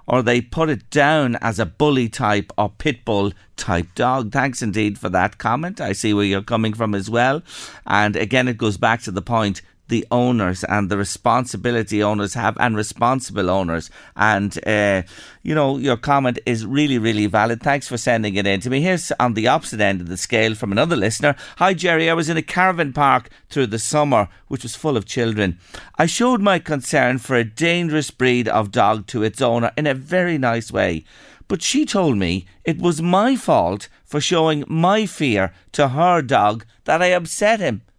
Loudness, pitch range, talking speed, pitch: -19 LUFS, 105-150 Hz, 200 wpm, 120 Hz